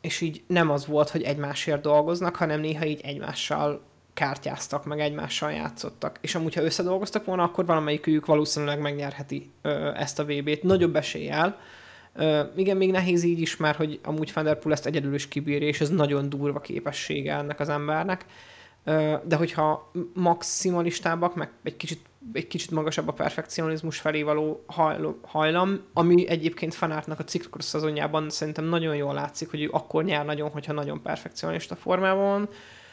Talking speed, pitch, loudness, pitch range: 155 wpm, 155 Hz, -27 LUFS, 150-170 Hz